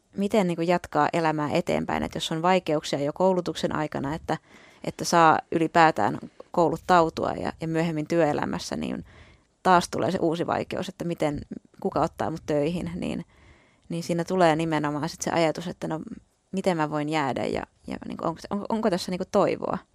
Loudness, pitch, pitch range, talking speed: -26 LUFS, 165 Hz, 155-180 Hz, 180 wpm